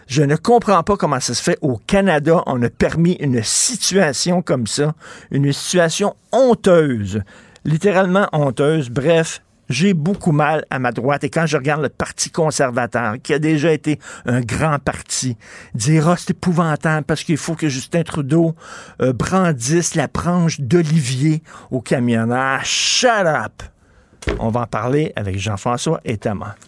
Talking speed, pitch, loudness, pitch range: 160 wpm, 150 Hz, -17 LUFS, 125-170 Hz